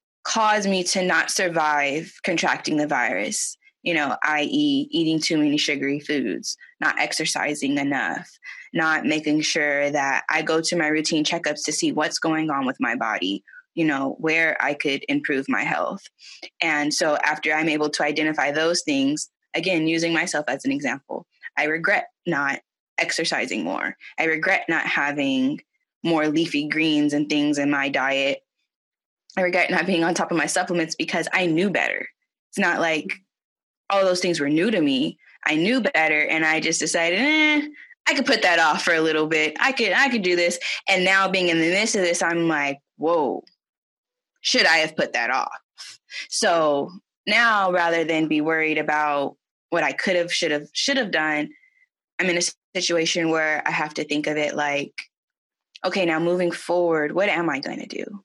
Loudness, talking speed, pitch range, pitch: -21 LUFS, 185 wpm, 150-195 Hz, 165 Hz